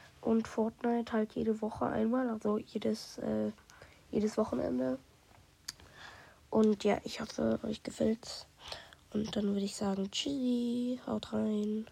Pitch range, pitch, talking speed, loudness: 210-230 Hz, 220 Hz, 125 wpm, -34 LUFS